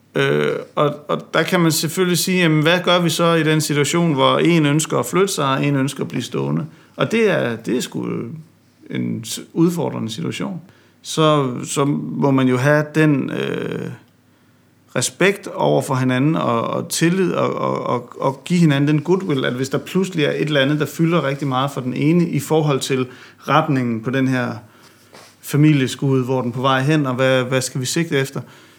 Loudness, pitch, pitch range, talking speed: -18 LUFS, 140 Hz, 130-160 Hz, 200 wpm